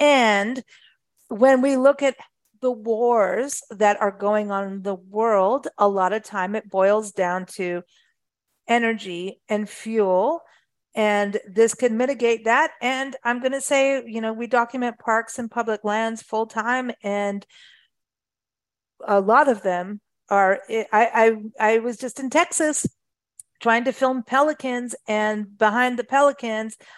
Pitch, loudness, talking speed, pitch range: 225 Hz, -21 LUFS, 145 wpm, 210-255 Hz